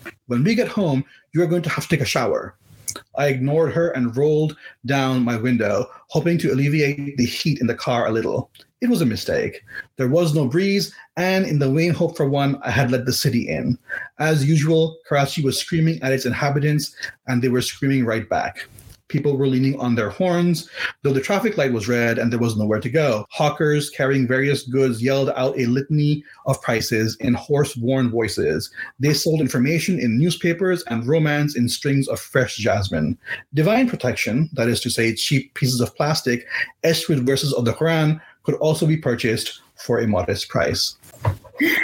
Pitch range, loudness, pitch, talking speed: 125-155 Hz, -20 LUFS, 140 Hz, 190 wpm